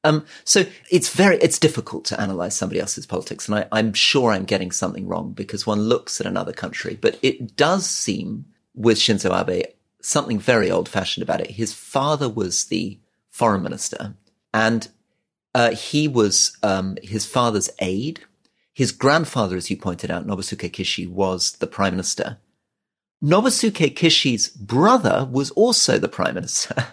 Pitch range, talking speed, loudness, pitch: 100-155 Hz, 160 wpm, -20 LUFS, 115 Hz